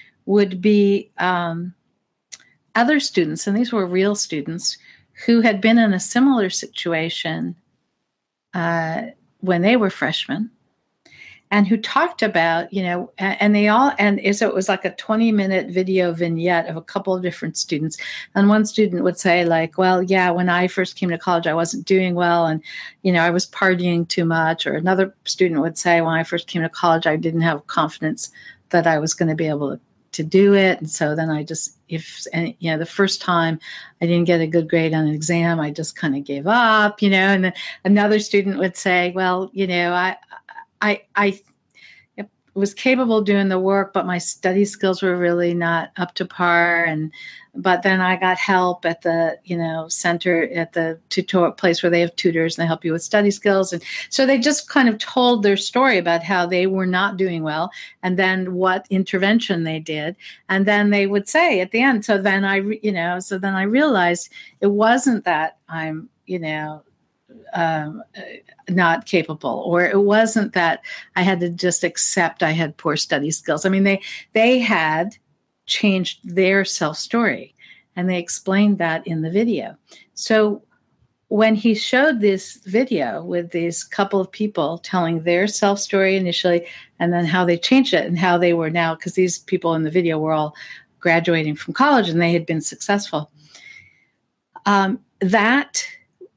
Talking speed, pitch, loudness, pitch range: 190 wpm, 185 Hz, -19 LUFS, 170-200 Hz